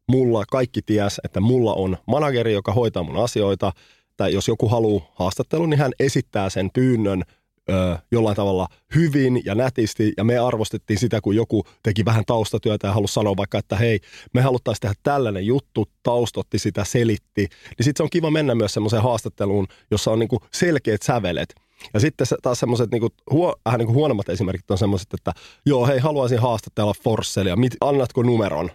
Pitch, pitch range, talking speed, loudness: 115 Hz, 100-125 Hz, 175 wpm, -21 LUFS